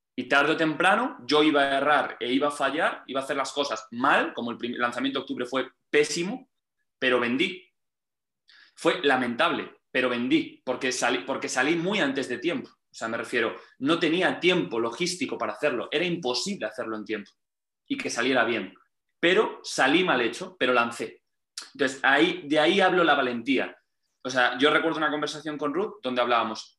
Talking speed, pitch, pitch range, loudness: 180 wpm, 145 Hz, 125-175 Hz, -25 LUFS